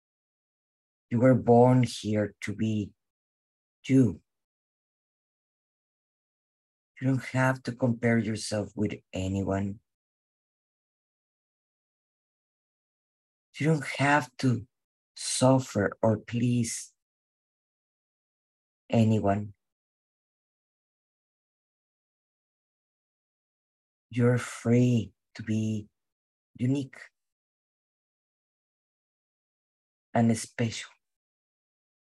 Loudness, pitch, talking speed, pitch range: -27 LUFS, 110 Hz, 55 wpm, 95-125 Hz